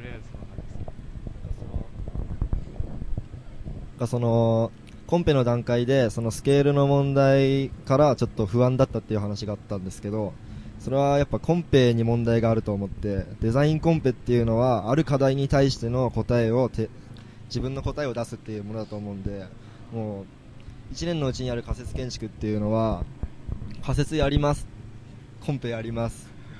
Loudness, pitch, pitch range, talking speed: -25 LUFS, 120 Hz, 110-135 Hz, 315 characters per minute